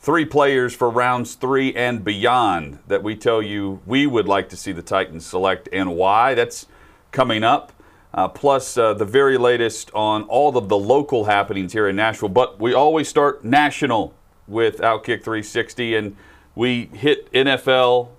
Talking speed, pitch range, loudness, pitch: 170 wpm, 105-130 Hz, -19 LUFS, 120 Hz